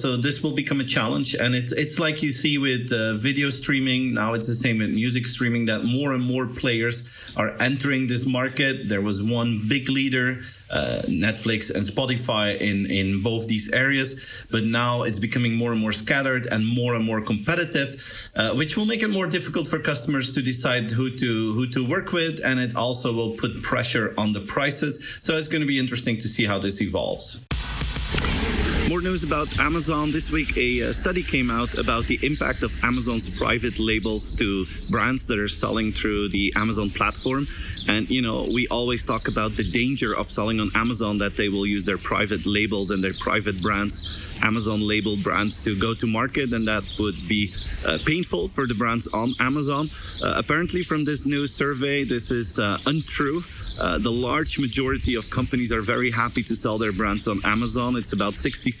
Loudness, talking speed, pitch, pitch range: -23 LUFS, 195 wpm, 120 Hz, 110-135 Hz